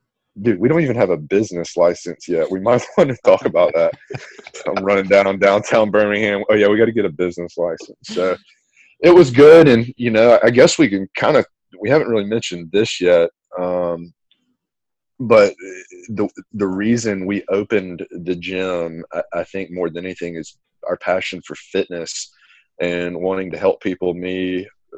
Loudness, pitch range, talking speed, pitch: -16 LUFS, 90-115 Hz, 185 wpm, 100 Hz